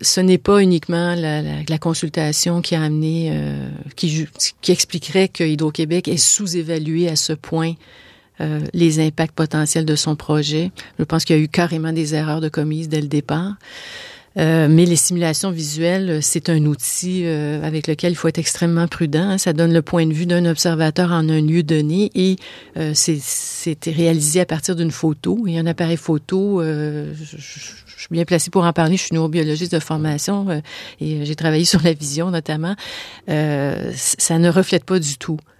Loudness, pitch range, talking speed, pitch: -18 LUFS, 155-175 Hz, 195 wpm, 165 Hz